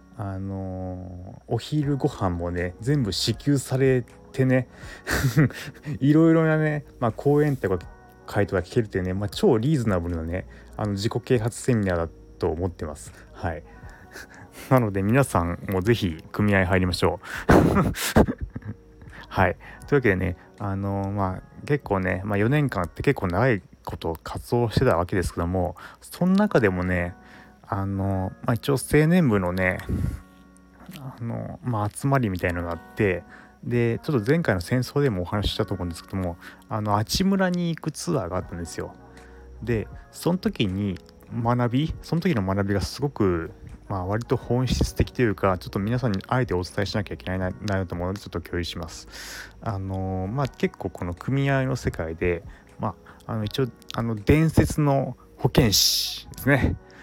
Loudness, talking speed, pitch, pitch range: -25 LUFS, 320 characters per minute, 105 Hz, 95-130 Hz